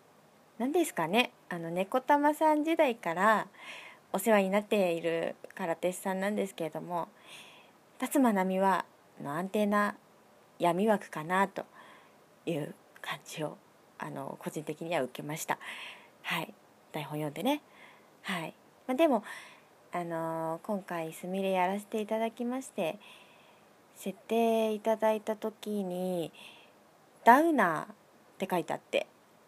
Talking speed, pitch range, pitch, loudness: 250 characters per minute, 175-230 Hz, 200 Hz, -31 LUFS